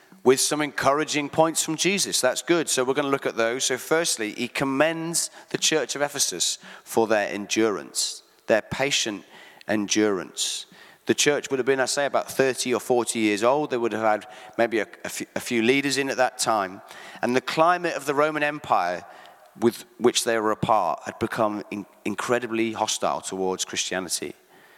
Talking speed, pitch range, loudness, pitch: 180 wpm, 110-145 Hz, -24 LUFS, 125 Hz